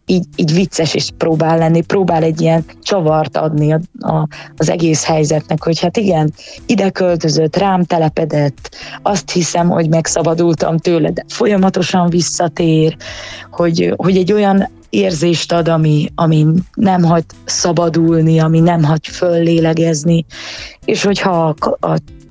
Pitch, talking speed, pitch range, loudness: 165 Hz, 135 wpm, 160-180 Hz, -13 LUFS